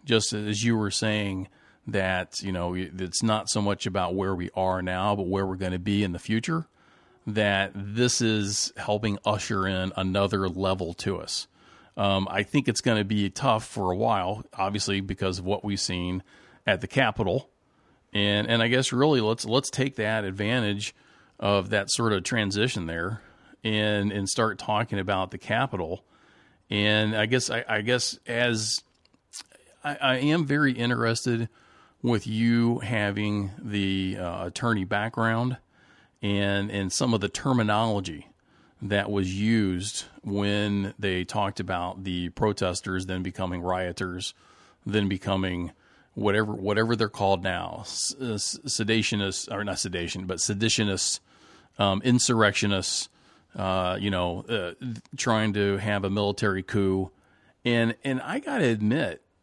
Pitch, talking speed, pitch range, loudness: 105 Hz, 150 wpm, 95-115 Hz, -27 LUFS